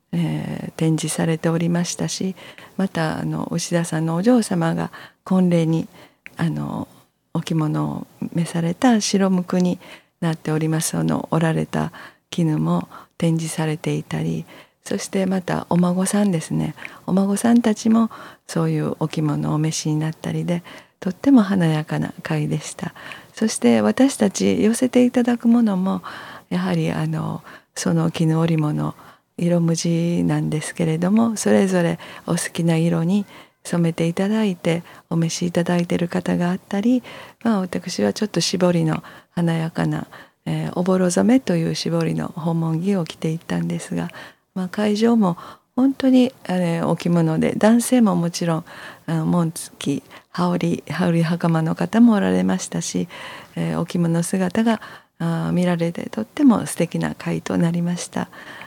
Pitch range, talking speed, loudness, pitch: 160-195 Hz, 300 characters per minute, -21 LUFS, 170 Hz